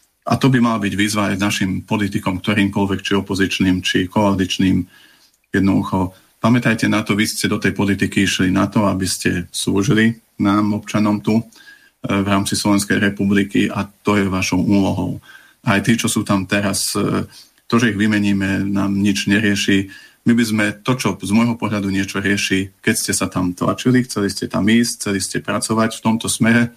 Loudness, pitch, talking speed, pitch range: -17 LUFS, 100 Hz, 175 wpm, 95-110 Hz